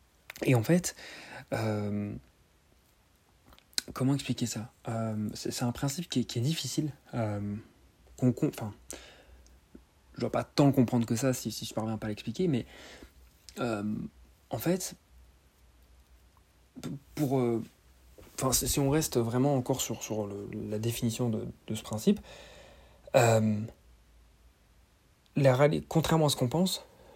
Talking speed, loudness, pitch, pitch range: 135 wpm, -31 LUFS, 115 Hz, 90-135 Hz